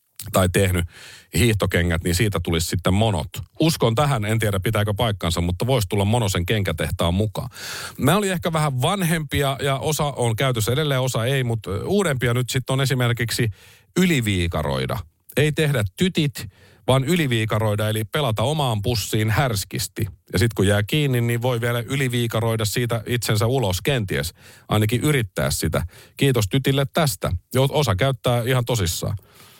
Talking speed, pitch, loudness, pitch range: 145 wpm, 120 Hz, -21 LUFS, 100-135 Hz